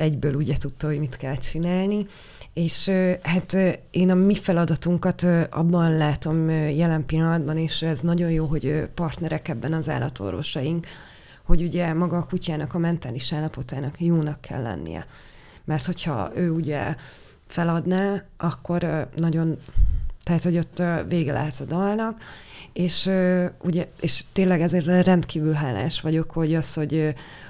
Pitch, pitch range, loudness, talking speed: 160 Hz, 150-175 Hz, -24 LUFS, 135 wpm